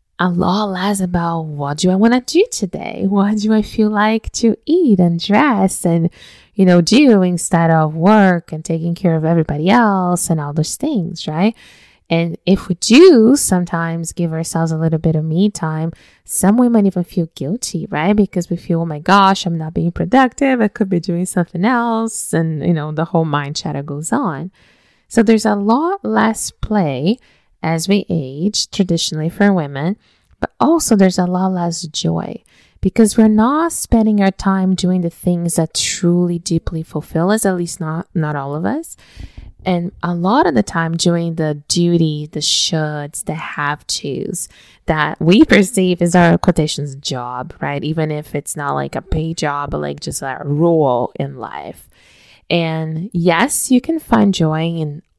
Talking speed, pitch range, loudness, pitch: 180 wpm, 160-205 Hz, -15 LUFS, 175 Hz